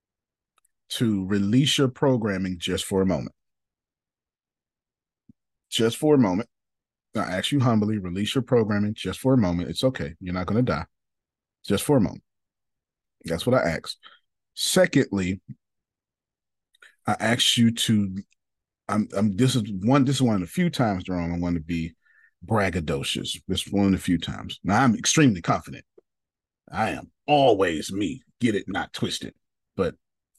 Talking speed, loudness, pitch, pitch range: 160 wpm, -24 LUFS, 100 Hz, 90-125 Hz